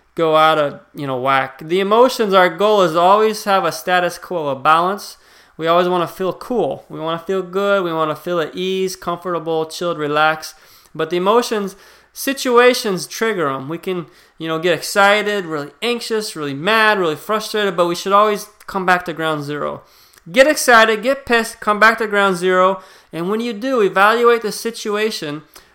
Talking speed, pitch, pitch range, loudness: 190 wpm, 185 Hz, 165-215 Hz, -16 LUFS